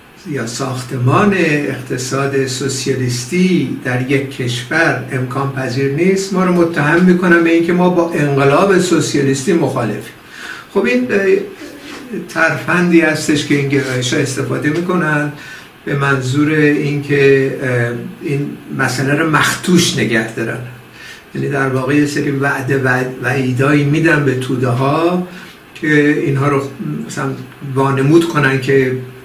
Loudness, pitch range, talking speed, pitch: -14 LUFS, 135-165 Hz, 120 wpm, 145 Hz